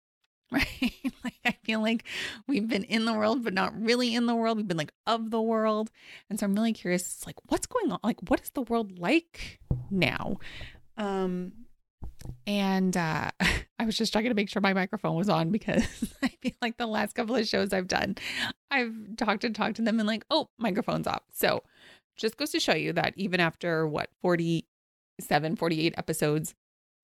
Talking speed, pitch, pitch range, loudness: 195 wpm, 220 Hz, 190-235 Hz, -29 LUFS